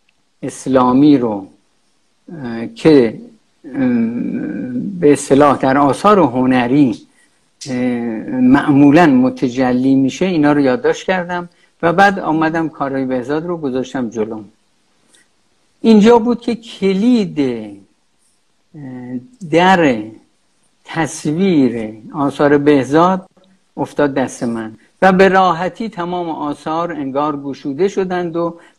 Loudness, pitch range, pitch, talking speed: -14 LUFS, 130-190 Hz, 150 Hz, 95 wpm